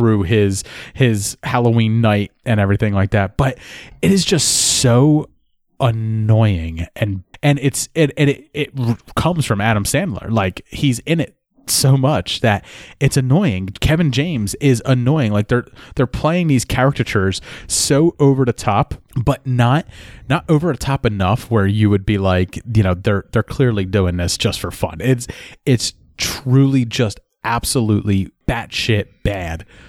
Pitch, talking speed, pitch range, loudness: 115 Hz, 155 wpm, 100-135 Hz, -17 LUFS